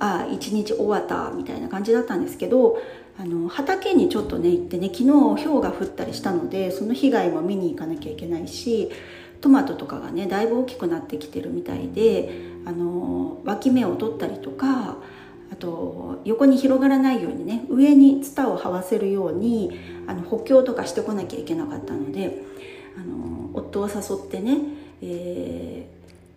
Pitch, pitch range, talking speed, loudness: 225 Hz, 175-275 Hz, 355 characters per minute, -22 LUFS